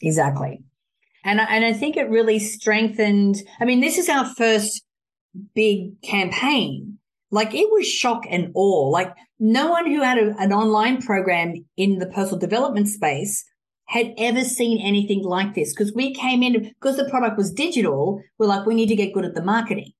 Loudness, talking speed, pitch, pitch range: -20 LUFS, 185 wpm, 215 Hz, 195-240 Hz